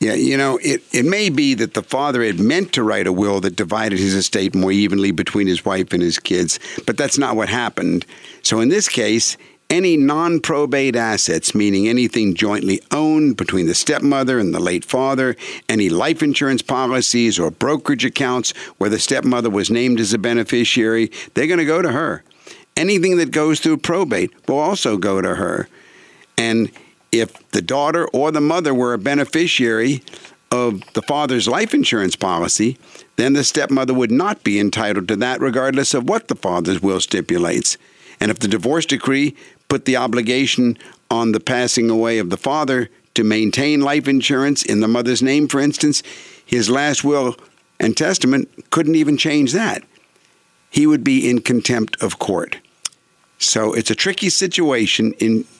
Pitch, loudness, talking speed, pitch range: 125 Hz, -17 LUFS, 175 wpm, 110-145 Hz